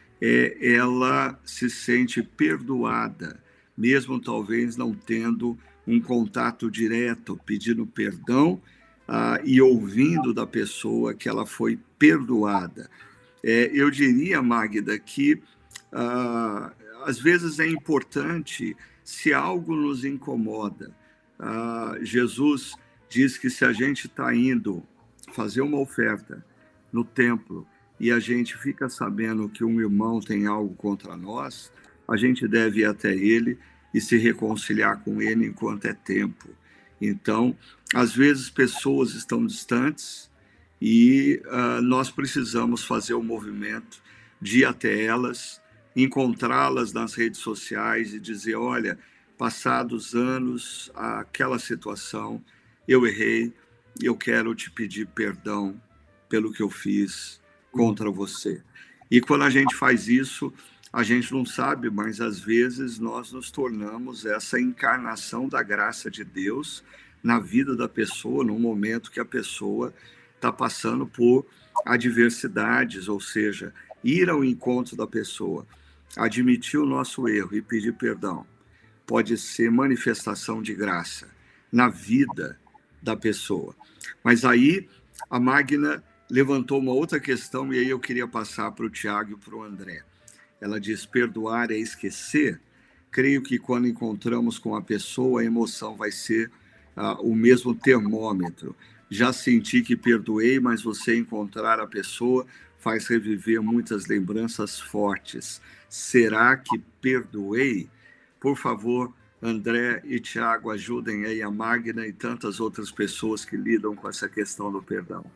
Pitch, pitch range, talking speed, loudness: 115 Hz, 105-125 Hz, 135 wpm, -24 LUFS